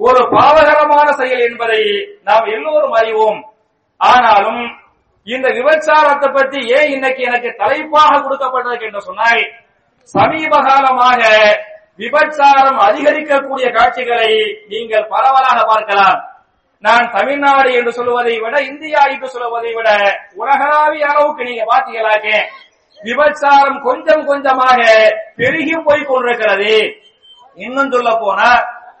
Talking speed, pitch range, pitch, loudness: 85 wpm, 225-290 Hz, 255 Hz, -11 LUFS